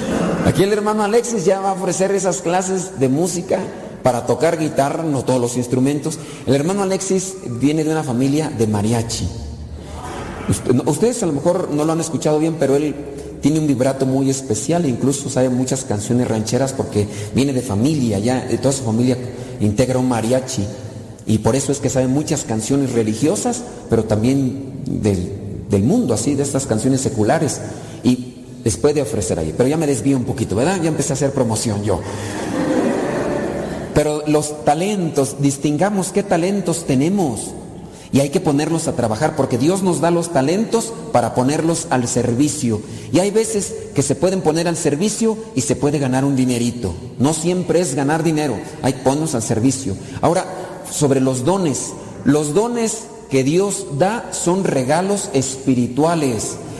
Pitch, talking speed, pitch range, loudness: 140 Hz, 165 wpm, 125-165 Hz, -18 LUFS